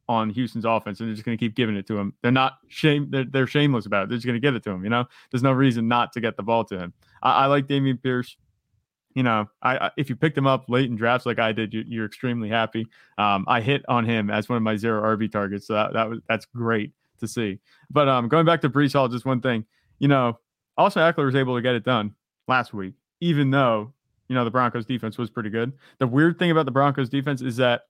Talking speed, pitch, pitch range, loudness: 270 wpm, 120 Hz, 110-135 Hz, -23 LUFS